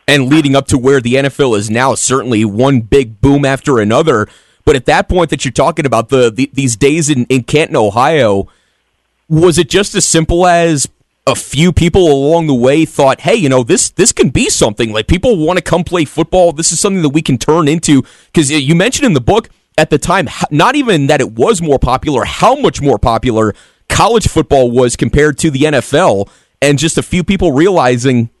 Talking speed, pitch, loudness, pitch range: 210 wpm, 145 Hz, -10 LUFS, 130-165 Hz